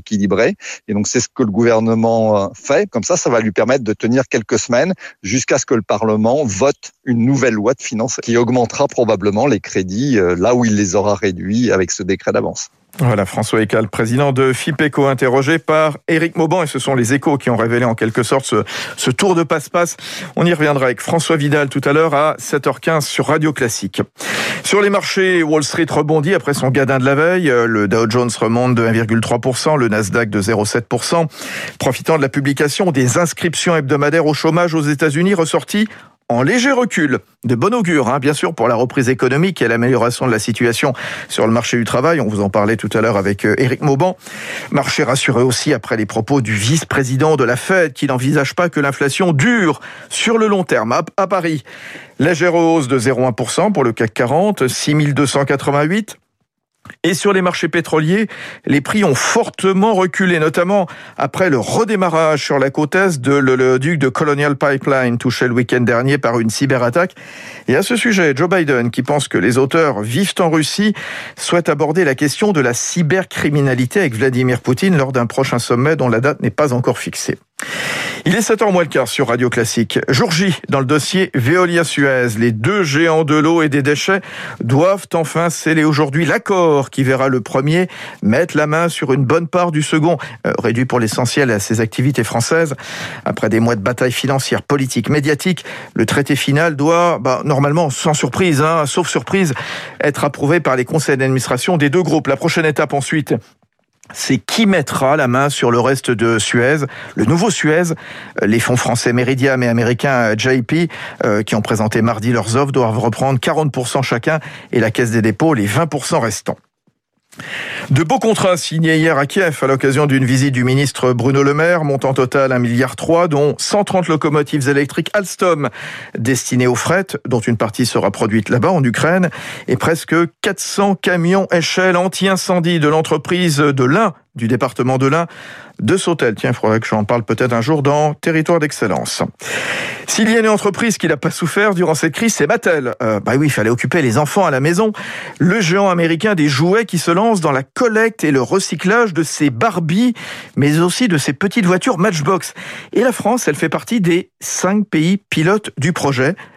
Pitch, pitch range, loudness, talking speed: 145 Hz, 125-170 Hz, -15 LUFS, 190 wpm